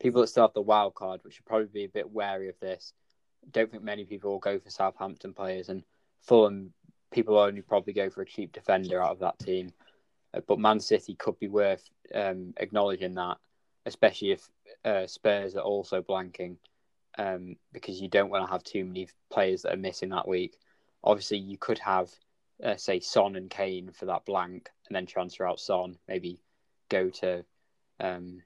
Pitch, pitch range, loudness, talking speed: 95 Hz, 90-100 Hz, -30 LUFS, 195 wpm